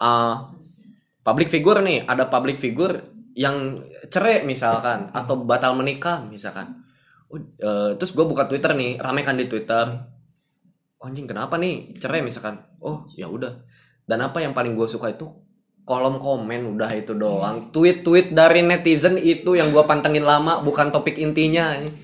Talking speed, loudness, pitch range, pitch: 160 wpm, -20 LUFS, 120-165 Hz, 140 Hz